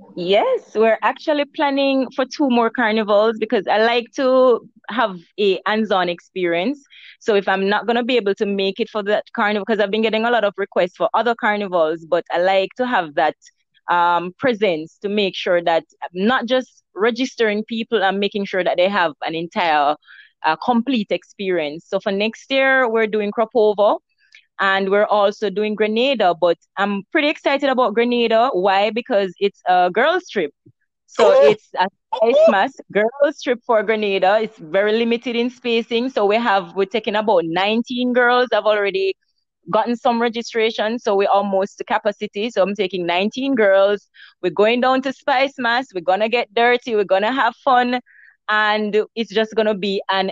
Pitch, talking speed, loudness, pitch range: 215 Hz, 180 wpm, -18 LUFS, 195-245 Hz